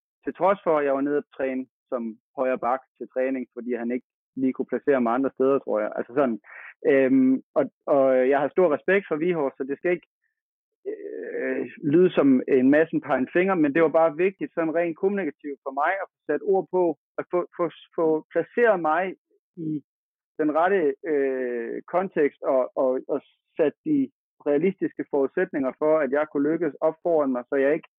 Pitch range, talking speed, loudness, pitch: 135-180 Hz, 195 wpm, -24 LUFS, 155 Hz